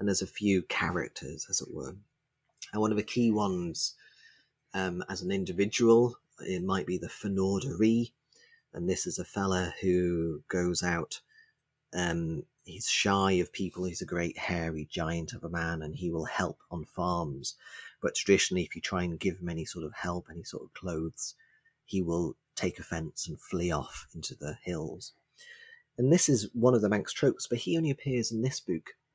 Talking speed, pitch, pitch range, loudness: 185 wpm, 95 Hz, 85-120 Hz, -31 LUFS